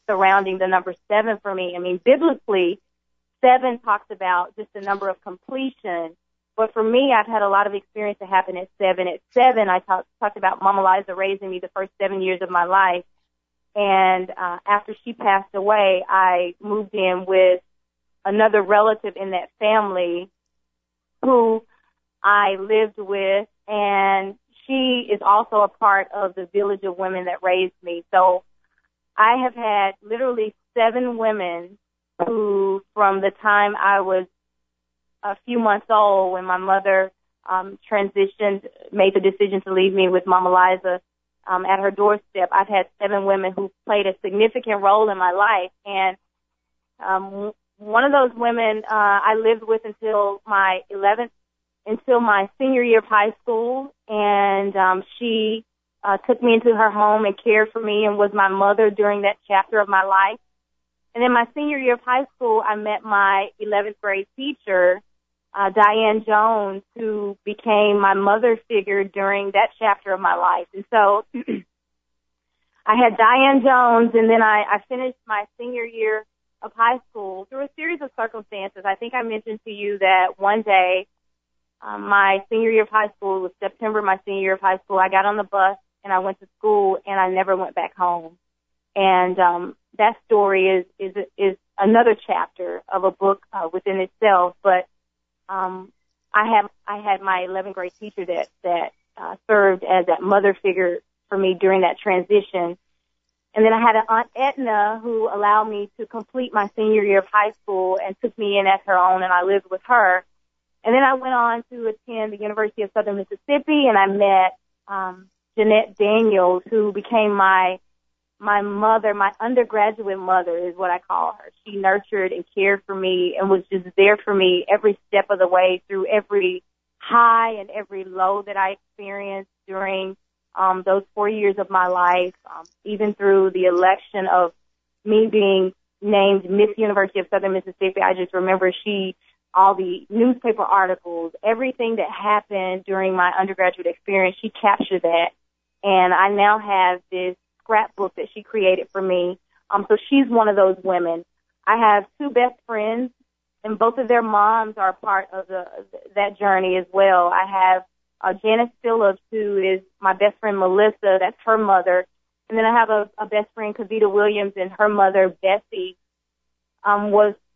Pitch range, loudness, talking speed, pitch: 185-215 Hz, -19 LUFS, 175 wpm, 200 Hz